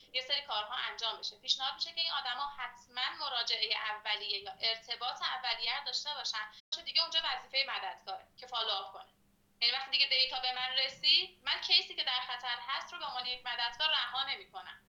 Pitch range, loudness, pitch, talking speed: 225-275 Hz, -33 LUFS, 250 Hz, 185 wpm